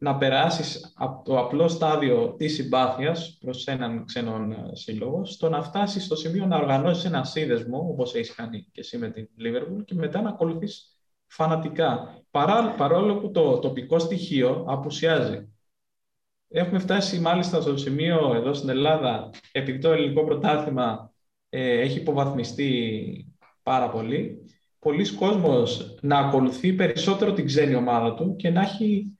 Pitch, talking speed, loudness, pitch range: 155 Hz, 145 wpm, -24 LUFS, 130-170 Hz